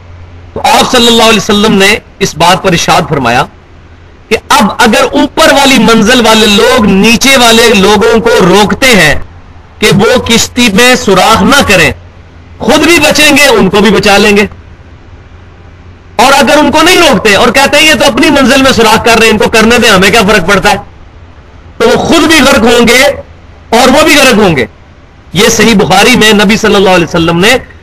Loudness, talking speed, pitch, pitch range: -4 LUFS, 195 wpm, 215 Hz, 175-250 Hz